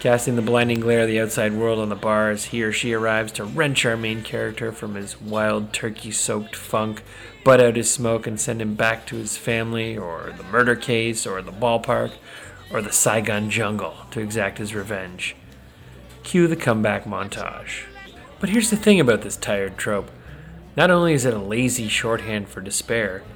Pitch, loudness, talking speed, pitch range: 110 Hz, -21 LUFS, 190 wpm, 105-120 Hz